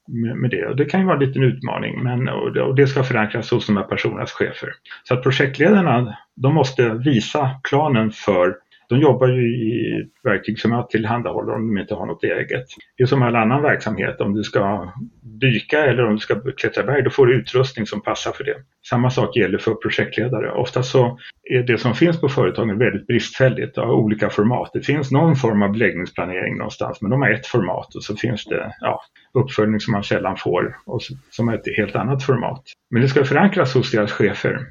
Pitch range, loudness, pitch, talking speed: 110-135 Hz, -19 LUFS, 125 Hz, 210 wpm